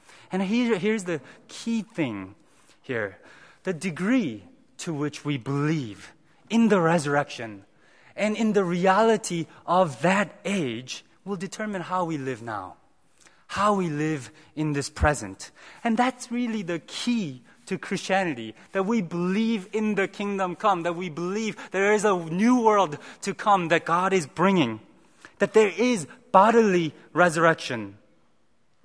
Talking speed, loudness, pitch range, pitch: 140 wpm, -25 LUFS, 155-210 Hz, 185 Hz